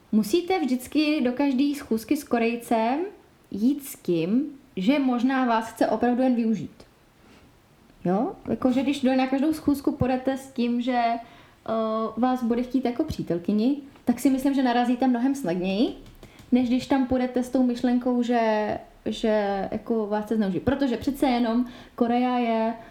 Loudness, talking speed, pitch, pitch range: -25 LUFS, 150 wpm, 250 Hz, 230-270 Hz